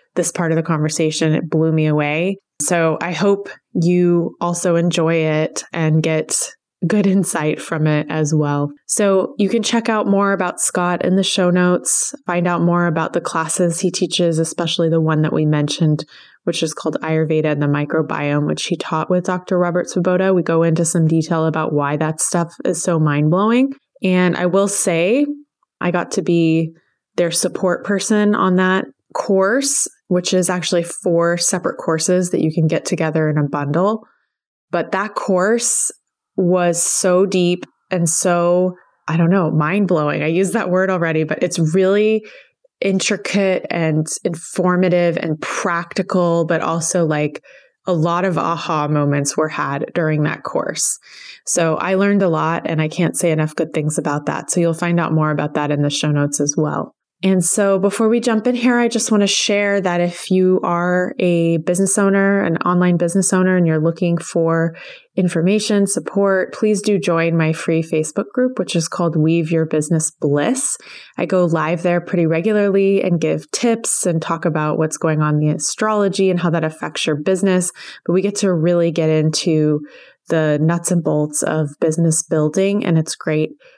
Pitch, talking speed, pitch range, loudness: 175 Hz, 180 wpm, 160-190 Hz, -17 LUFS